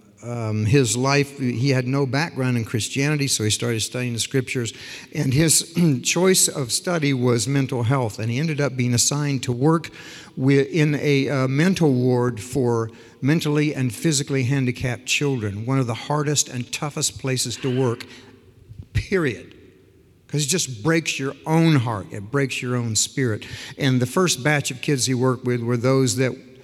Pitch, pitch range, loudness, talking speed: 130 Hz, 120-145 Hz, -21 LUFS, 175 wpm